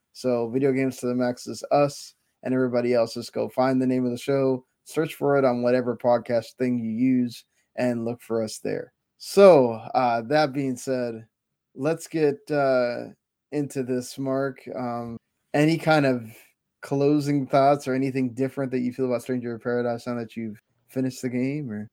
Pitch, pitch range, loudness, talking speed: 130 Hz, 120-140 Hz, -24 LUFS, 185 wpm